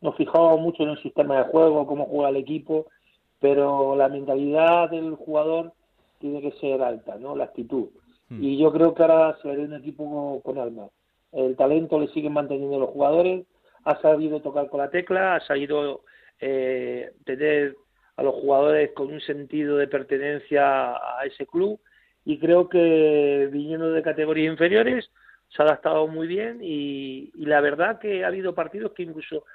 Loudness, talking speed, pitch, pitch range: -23 LUFS, 175 wpm, 150 Hz, 140-160 Hz